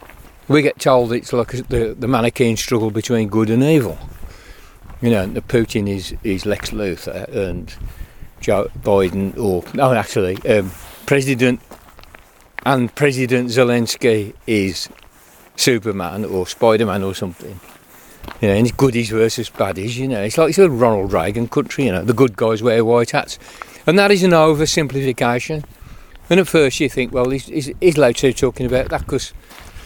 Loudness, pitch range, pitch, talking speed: -17 LUFS, 105-135 Hz, 120 Hz, 165 wpm